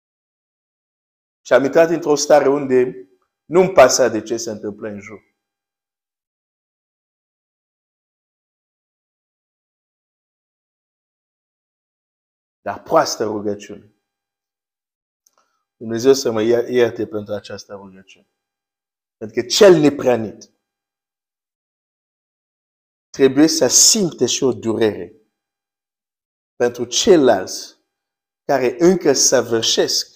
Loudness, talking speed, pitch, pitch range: -15 LUFS, 80 wpm, 110 Hz, 100-135 Hz